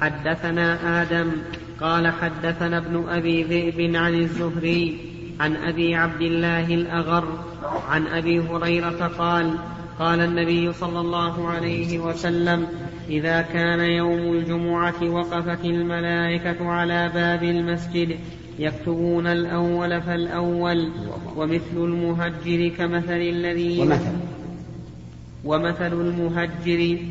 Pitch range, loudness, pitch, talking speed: 165-170 Hz, -23 LUFS, 170 Hz, 95 wpm